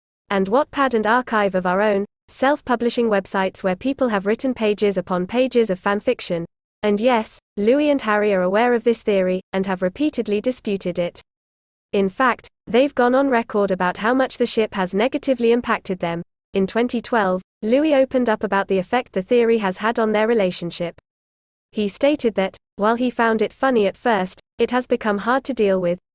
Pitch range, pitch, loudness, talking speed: 195-245 Hz, 220 Hz, -20 LUFS, 185 wpm